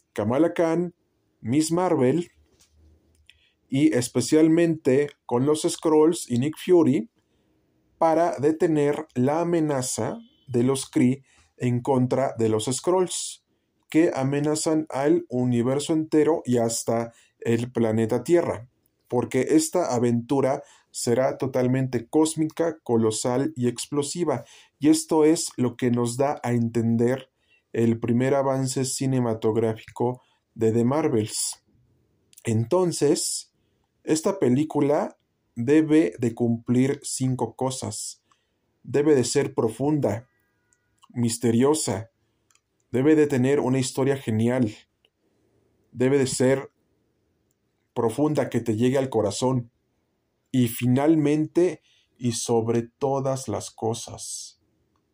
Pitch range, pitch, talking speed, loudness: 115-150 Hz, 125 Hz, 100 wpm, -24 LUFS